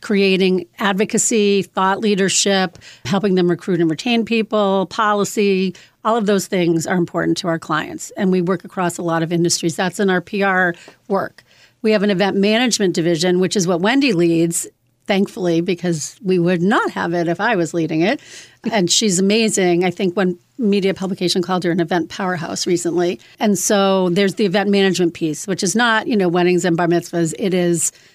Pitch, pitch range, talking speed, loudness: 185 Hz, 175-200 Hz, 190 wpm, -17 LUFS